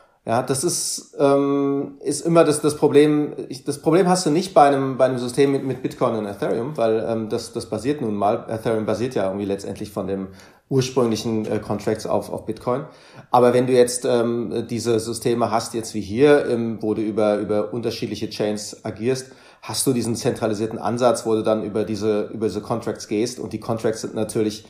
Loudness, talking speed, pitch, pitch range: -21 LUFS, 200 wpm, 115 Hz, 110-130 Hz